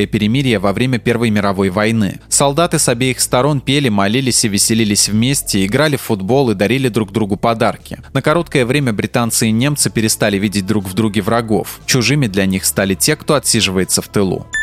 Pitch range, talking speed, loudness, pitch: 105-130 Hz, 180 wpm, -14 LUFS, 115 Hz